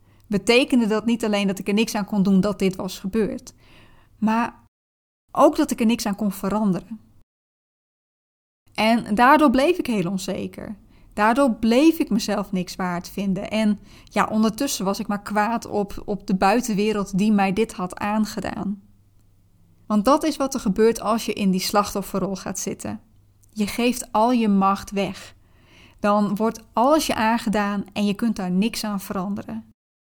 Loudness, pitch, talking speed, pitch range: -22 LUFS, 205 Hz, 165 wpm, 190-225 Hz